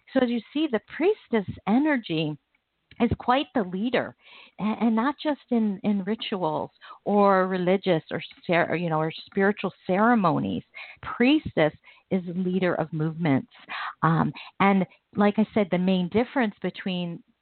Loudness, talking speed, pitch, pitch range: -25 LUFS, 135 wpm, 205 Hz, 180-235 Hz